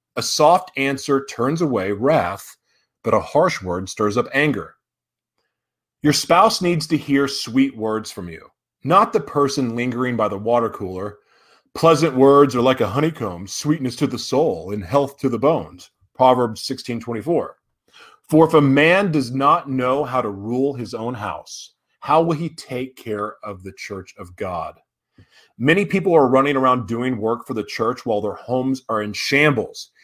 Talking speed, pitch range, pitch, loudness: 170 wpm, 115-145 Hz, 130 Hz, -19 LUFS